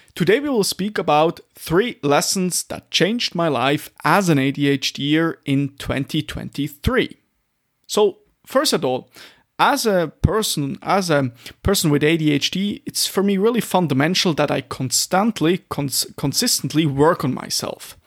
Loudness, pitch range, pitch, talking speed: -19 LUFS, 140-190 Hz, 155 Hz, 135 wpm